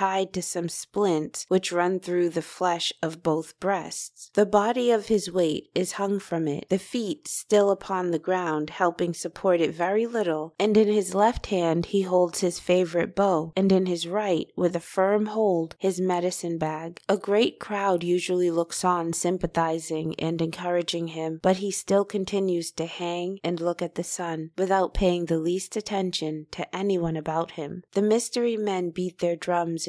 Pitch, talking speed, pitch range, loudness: 180 Hz, 180 wpm, 170-195 Hz, -26 LUFS